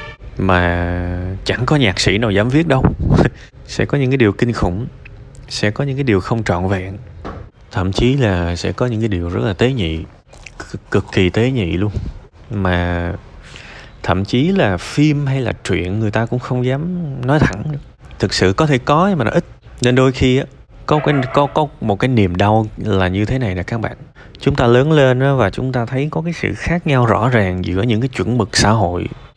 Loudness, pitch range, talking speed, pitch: -16 LUFS, 95-135 Hz, 220 wpm, 115 Hz